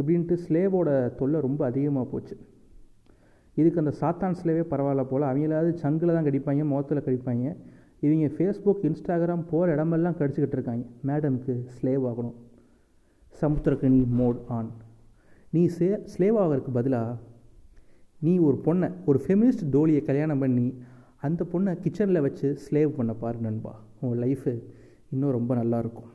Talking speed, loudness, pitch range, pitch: 130 wpm, -26 LUFS, 125-165 Hz, 140 Hz